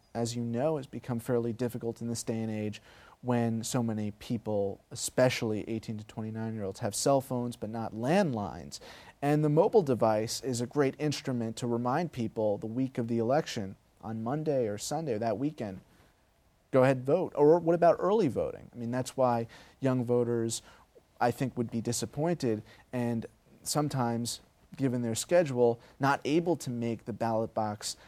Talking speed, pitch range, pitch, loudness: 175 wpm, 110-130 Hz, 120 Hz, -31 LUFS